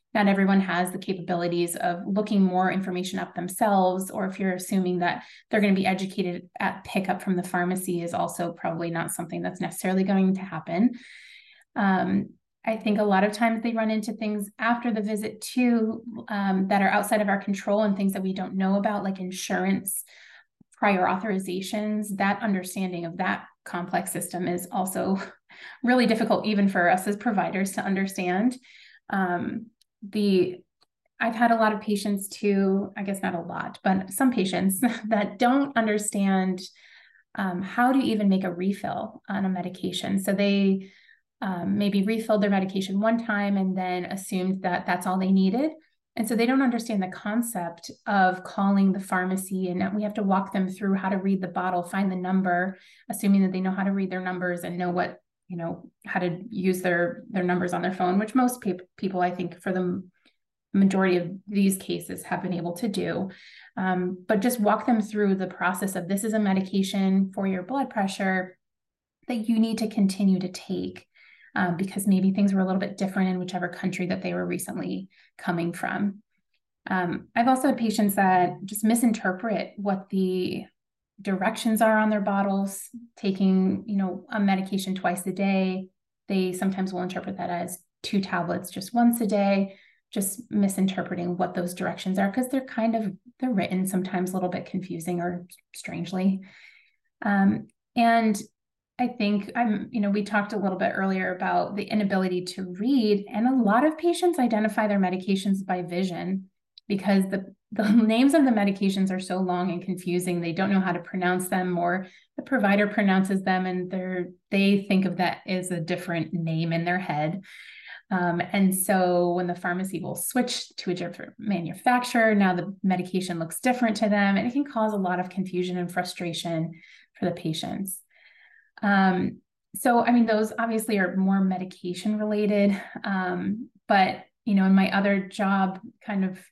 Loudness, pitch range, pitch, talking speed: -26 LUFS, 185-215 Hz, 195 Hz, 180 wpm